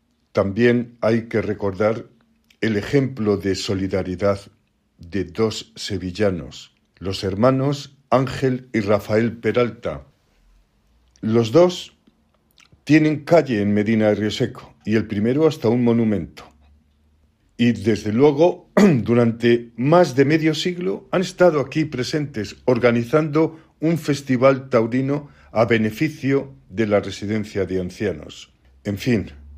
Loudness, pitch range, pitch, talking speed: -20 LUFS, 100-135 Hz, 115 Hz, 115 wpm